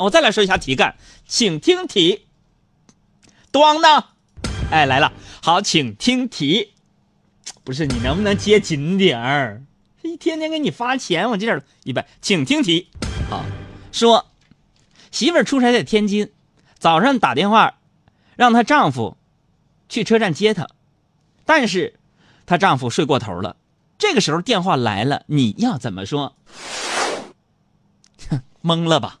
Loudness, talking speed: -18 LUFS, 200 characters per minute